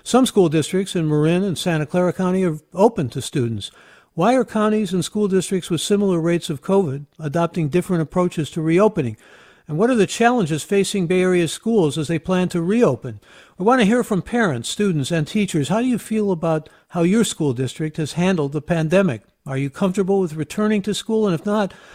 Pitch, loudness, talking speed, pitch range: 180 Hz, -20 LUFS, 205 wpm, 160-205 Hz